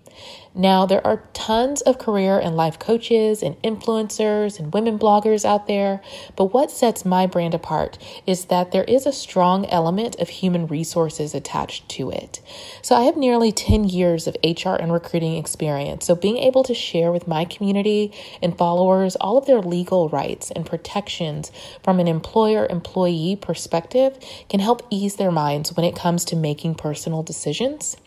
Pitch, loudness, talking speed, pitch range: 185 Hz, -20 LUFS, 170 wpm, 170-220 Hz